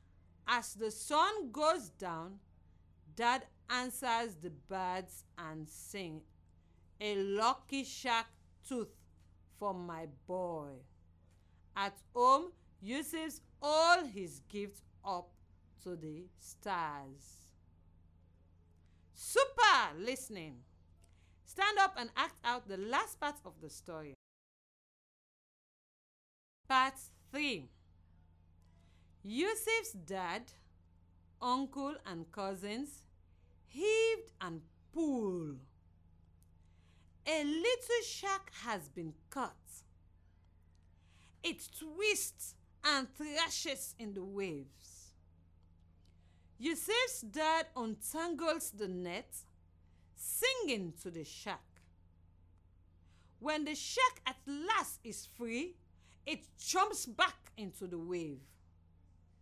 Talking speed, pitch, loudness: 85 wpm, 180 Hz, -37 LUFS